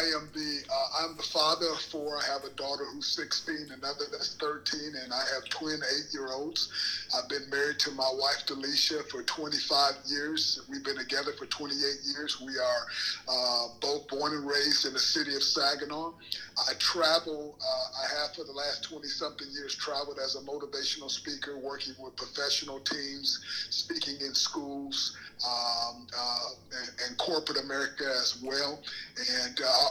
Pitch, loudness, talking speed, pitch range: 145 Hz, -31 LUFS, 165 wpm, 135-155 Hz